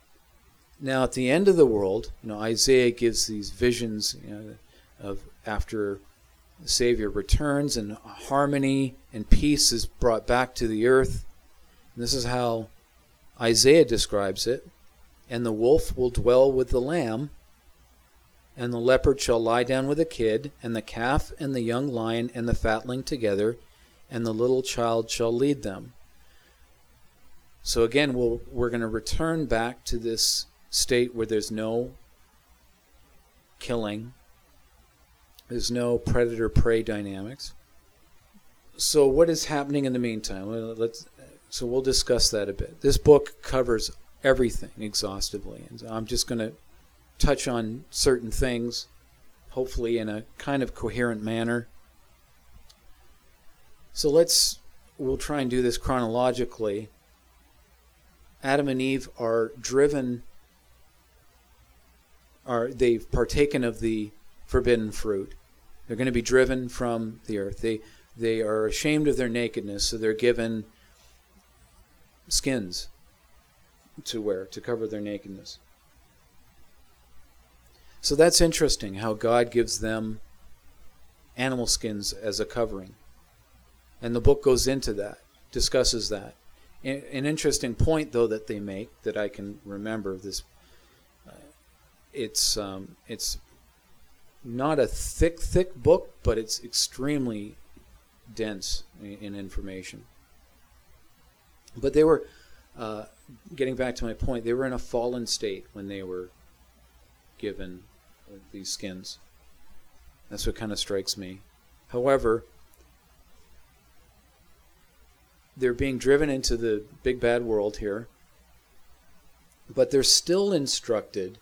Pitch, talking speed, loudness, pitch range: 110 Hz, 130 wpm, -26 LUFS, 80-125 Hz